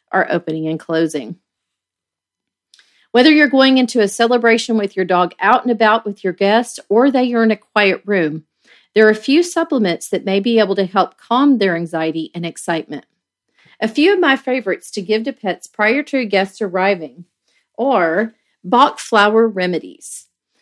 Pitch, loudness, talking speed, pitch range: 210 Hz, -15 LUFS, 170 wpm, 185-245 Hz